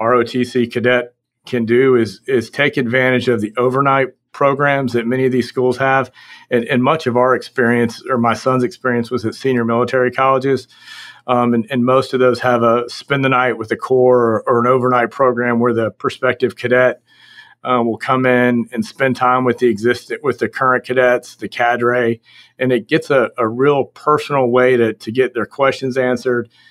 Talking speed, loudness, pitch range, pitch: 195 wpm, -16 LUFS, 120-130 Hz, 125 Hz